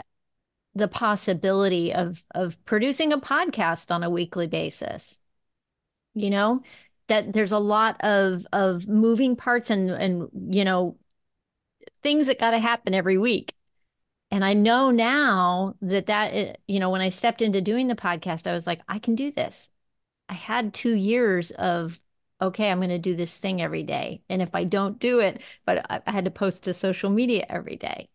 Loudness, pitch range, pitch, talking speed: -24 LUFS, 185-230 Hz, 200 Hz, 180 wpm